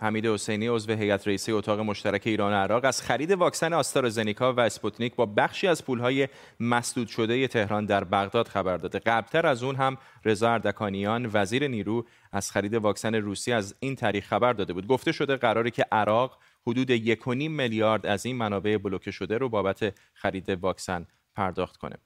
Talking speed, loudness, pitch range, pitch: 175 wpm, -27 LUFS, 100-120 Hz, 110 Hz